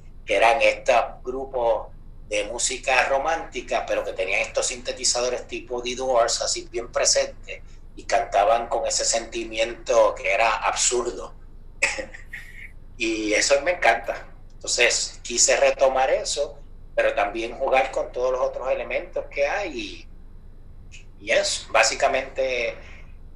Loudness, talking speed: -22 LUFS, 120 wpm